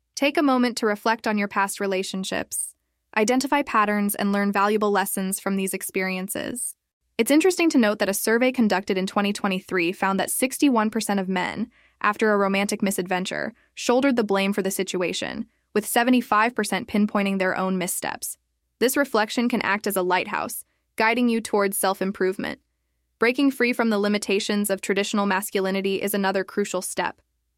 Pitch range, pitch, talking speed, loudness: 195-230 Hz, 205 Hz, 160 wpm, -23 LUFS